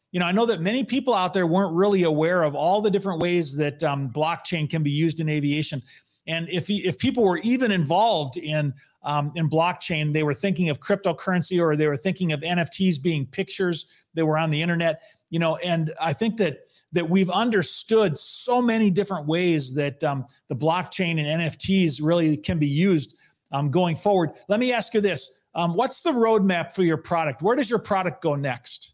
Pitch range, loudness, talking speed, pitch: 155-195 Hz, -23 LUFS, 205 wpm, 170 Hz